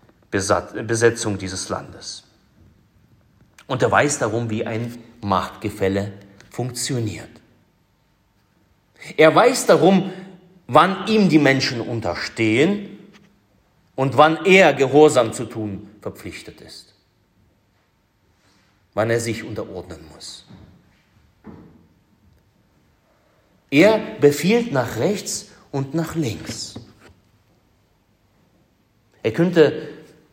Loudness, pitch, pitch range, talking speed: -19 LUFS, 115 Hz, 100-145 Hz, 80 wpm